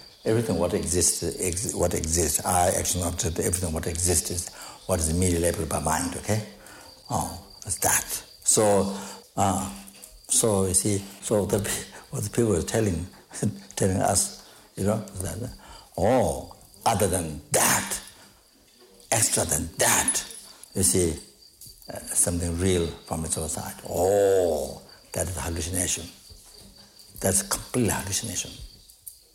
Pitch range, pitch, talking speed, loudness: 85-100 Hz, 90 Hz, 130 wpm, -25 LUFS